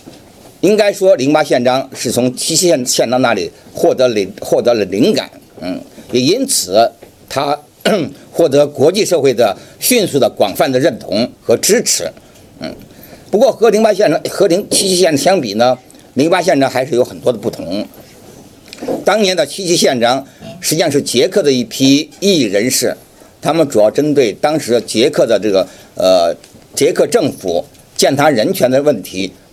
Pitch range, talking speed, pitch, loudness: 125-175 Hz, 245 characters per minute, 145 Hz, -13 LUFS